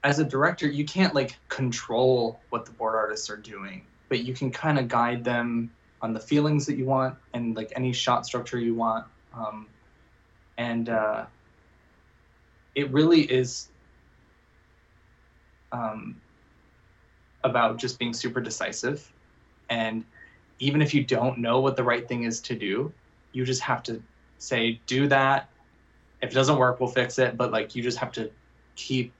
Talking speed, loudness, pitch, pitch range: 160 wpm, -26 LUFS, 120 Hz, 110-130 Hz